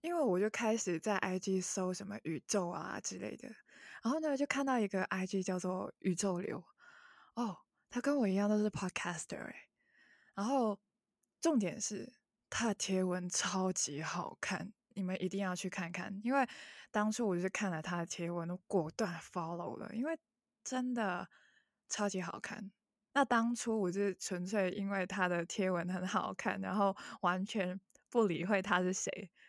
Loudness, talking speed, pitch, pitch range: -37 LUFS, 265 characters per minute, 195 Hz, 185-220 Hz